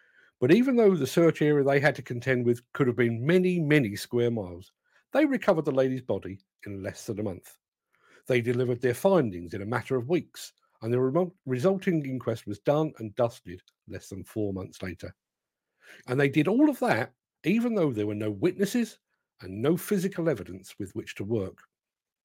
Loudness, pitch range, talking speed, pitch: -27 LUFS, 110-170 Hz, 190 wpm, 130 Hz